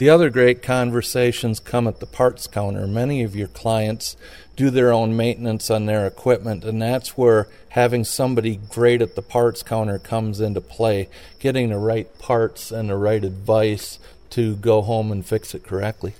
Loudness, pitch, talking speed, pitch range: -20 LUFS, 115 Hz, 180 wpm, 105-120 Hz